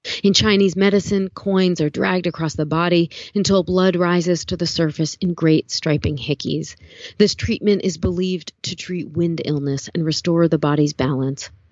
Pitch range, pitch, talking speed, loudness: 150-185 Hz, 170 Hz, 165 wpm, -19 LUFS